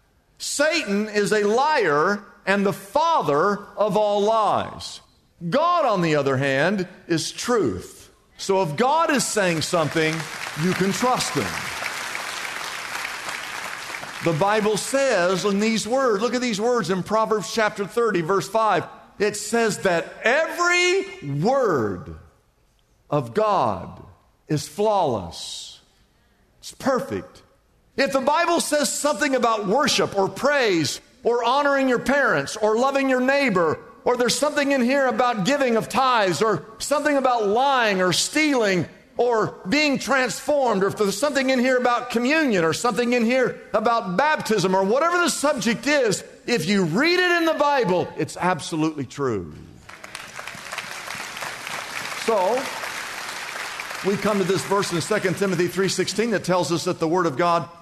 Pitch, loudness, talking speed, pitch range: 215 Hz, -22 LUFS, 140 wpm, 190-265 Hz